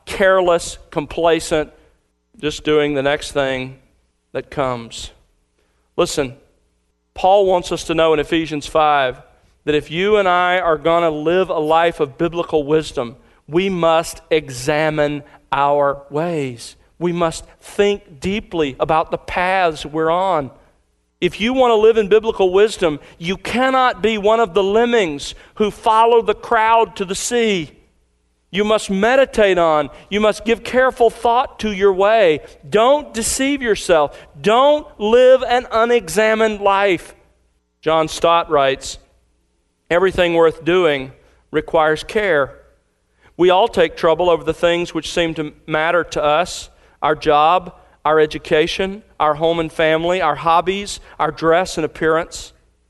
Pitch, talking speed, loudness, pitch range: 165 Hz, 140 wpm, -17 LUFS, 150-200 Hz